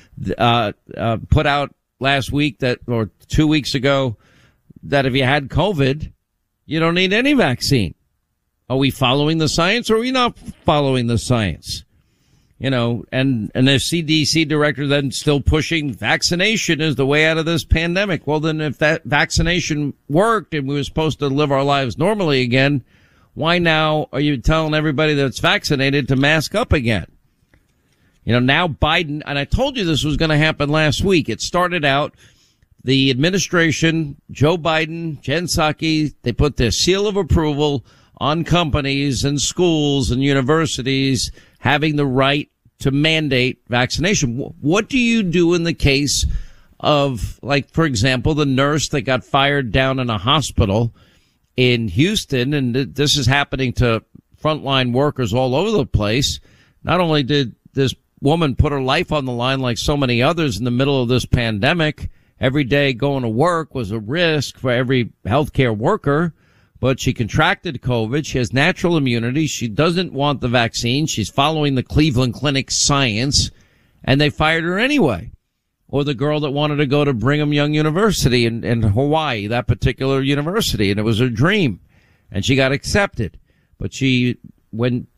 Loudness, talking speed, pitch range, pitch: -17 LUFS, 170 wpm, 125-155 Hz, 140 Hz